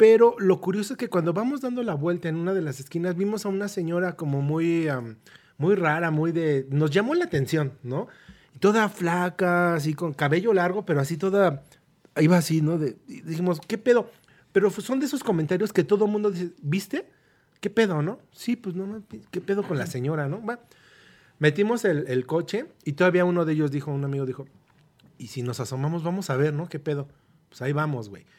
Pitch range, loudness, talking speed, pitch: 150-200 Hz, -25 LUFS, 210 wpm, 170 Hz